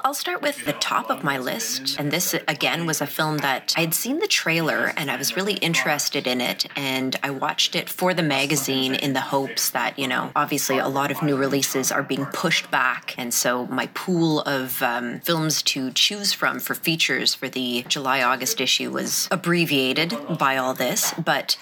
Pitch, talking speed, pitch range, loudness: 145 Hz, 205 wpm, 135-165 Hz, -22 LUFS